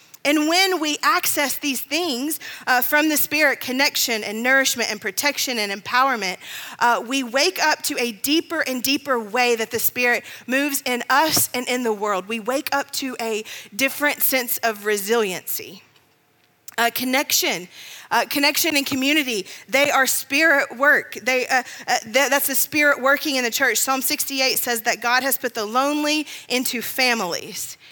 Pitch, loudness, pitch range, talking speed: 260 Hz, -20 LUFS, 235-285 Hz, 170 wpm